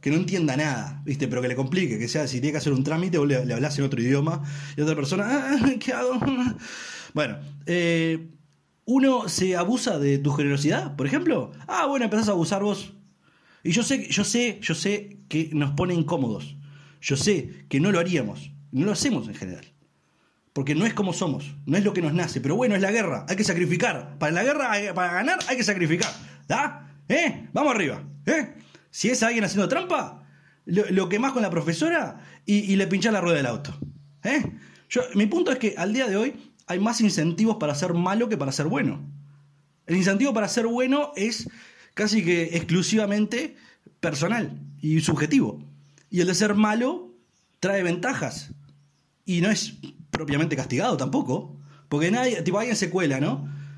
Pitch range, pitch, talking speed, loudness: 145-210 Hz, 175 Hz, 190 wpm, -24 LUFS